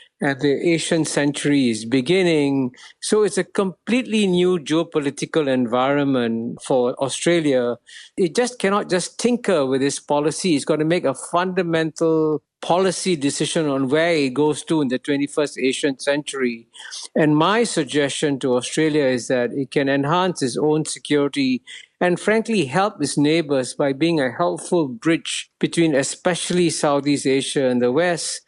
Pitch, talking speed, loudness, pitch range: 155 Hz, 145 wpm, -20 LUFS, 140-175 Hz